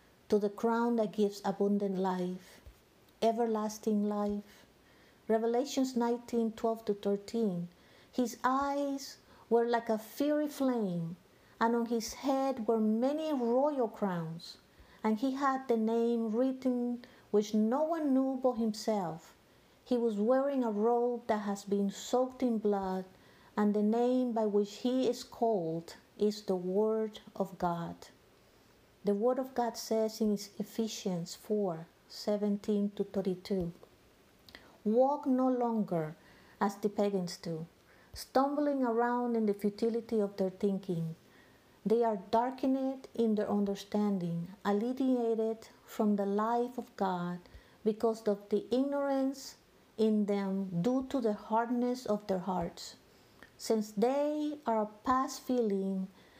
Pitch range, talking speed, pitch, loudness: 200-245 Hz, 130 wpm, 220 Hz, -33 LUFS